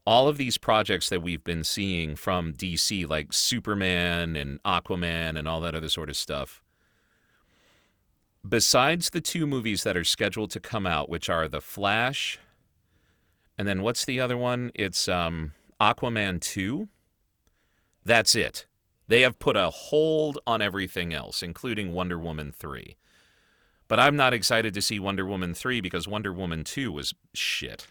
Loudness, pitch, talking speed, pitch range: -26 LUFS, 95 Hz, 160 wpm, 85-110 Hz